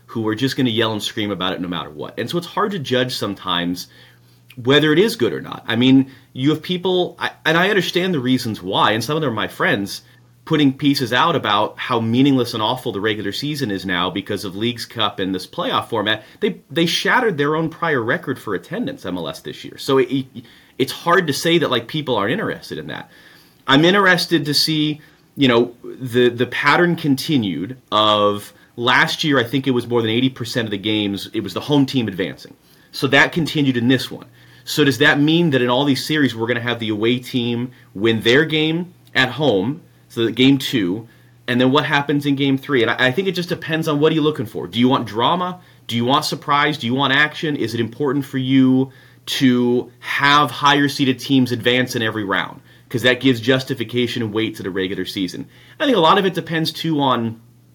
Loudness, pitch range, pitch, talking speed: -18 LUFS, 115-150 Hz, 130 Hz, 220 wpm